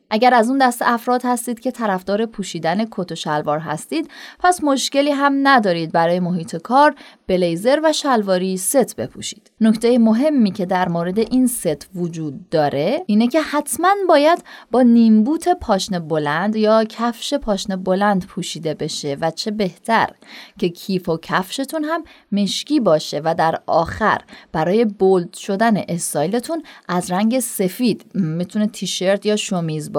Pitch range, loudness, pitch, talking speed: 180-250 Hz, -18 LUFS, 210 Hz, 145 wpm